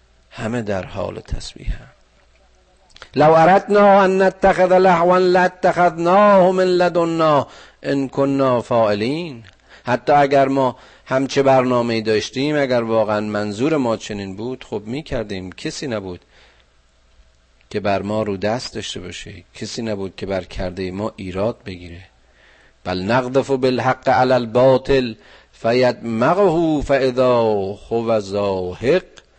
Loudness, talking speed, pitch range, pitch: -17 LUFS, 120 wpm, 100-140 Hz, 120 Hz